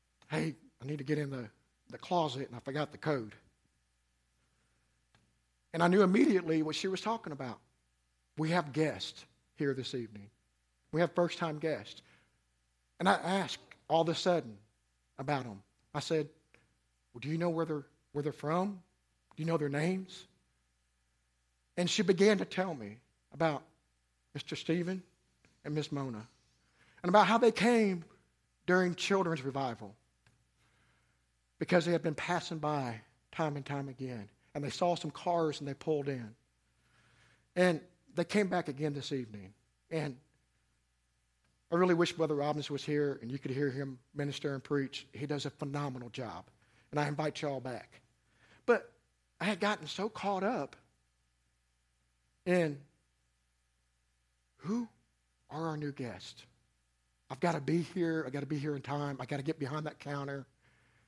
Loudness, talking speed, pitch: -34 LUFS, 160 wpm, 140 Hz